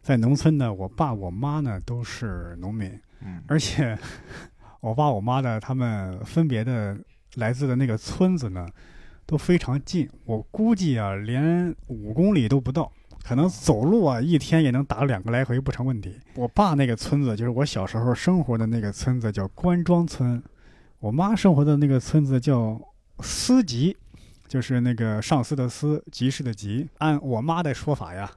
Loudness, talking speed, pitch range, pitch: -24 LUFS, 255 characters per minute, 110-150 Hz, 130 Hz